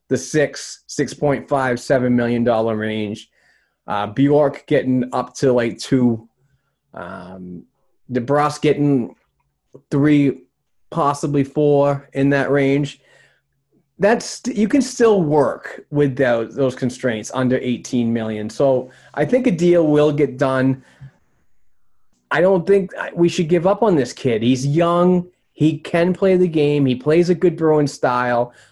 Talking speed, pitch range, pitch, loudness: 140 wpm, 125-155 Hz, 140 Hz, -18 LUFS